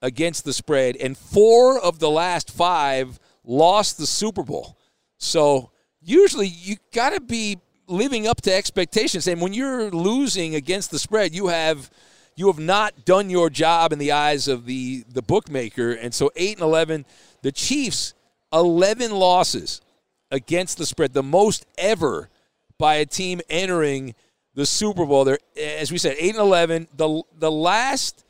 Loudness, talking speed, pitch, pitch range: -20 LUFS, 160 wpm, 170 Hz, 145-195 Hz